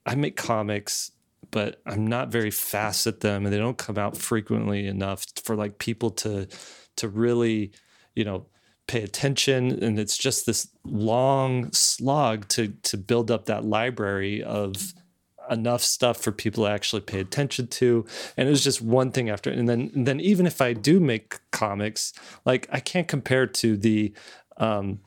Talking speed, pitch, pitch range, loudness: 175 wpm, 115 Hz, 105-125 Hz, -25 LUFS